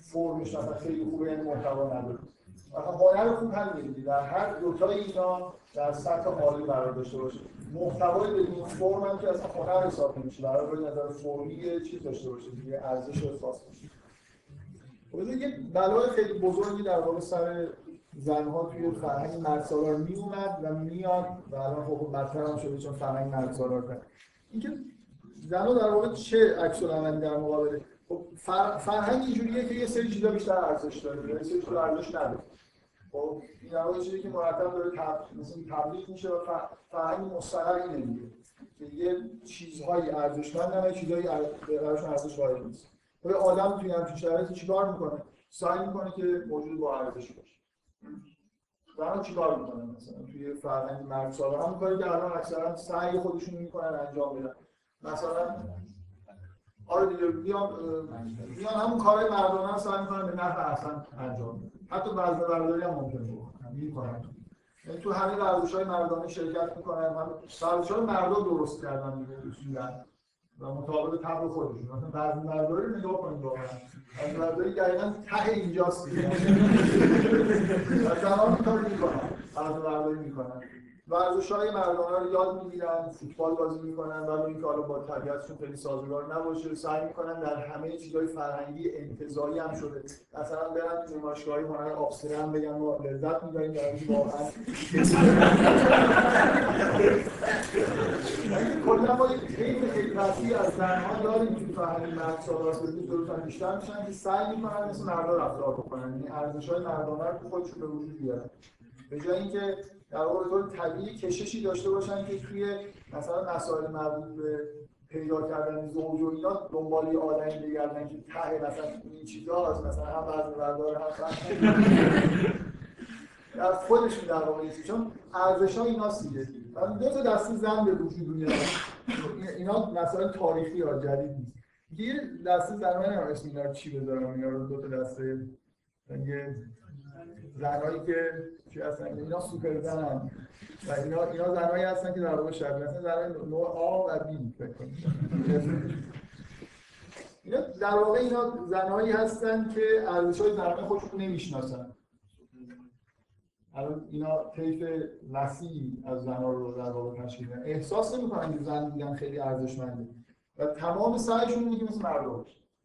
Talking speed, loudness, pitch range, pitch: 145 wpm, -29 LUFS, 145-185 Hz, 160 Hz